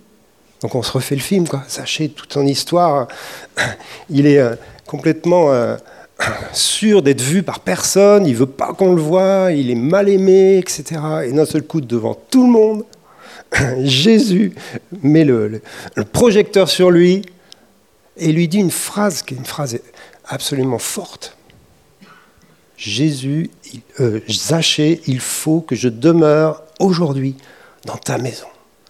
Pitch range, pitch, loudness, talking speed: 135-190 Hz, 155 Hz, -15 LUFS, 145 wpm